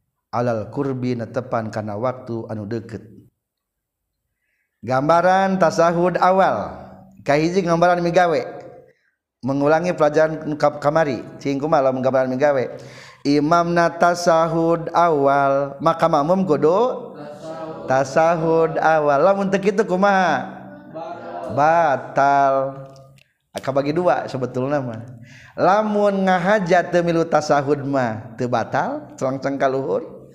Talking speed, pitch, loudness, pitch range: 95 wpm, 145 Hz, -19 LUFS, 130-170 Hz